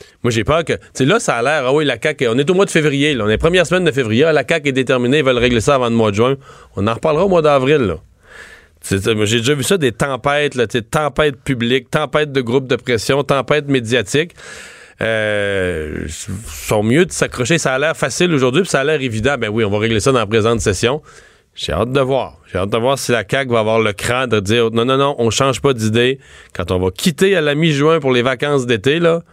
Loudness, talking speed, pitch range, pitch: -15 LUFS, 260 wpm, 115-145 Hz, 130 Hz